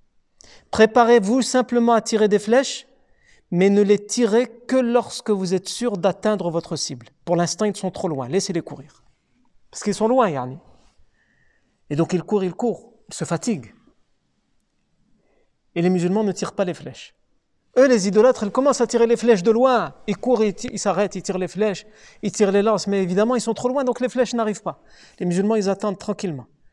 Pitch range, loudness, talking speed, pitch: 185-235 Hz, -20 LUFS, 200 wpm, 210 Hz